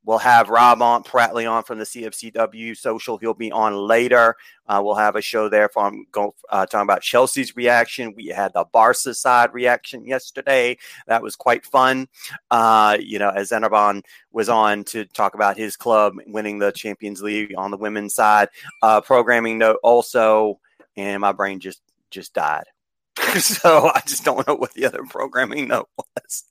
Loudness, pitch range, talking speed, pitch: -18 LUFS, 105-120 Hz, 180 wpm, 110 Hz